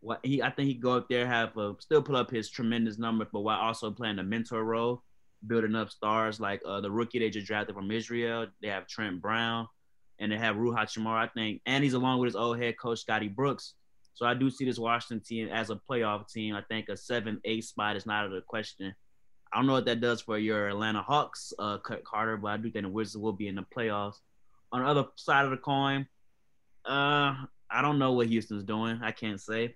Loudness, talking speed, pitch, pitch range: -31 LUFS, 245 wpm, 115 Hz, 105-120 Hz